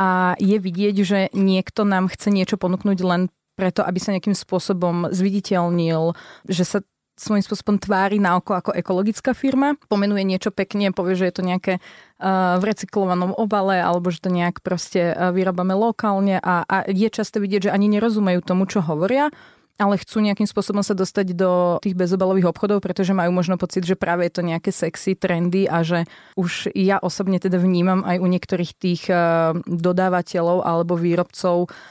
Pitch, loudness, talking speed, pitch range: 185 Hz, -20 LUFS, 170 wpm, 180-200 Hz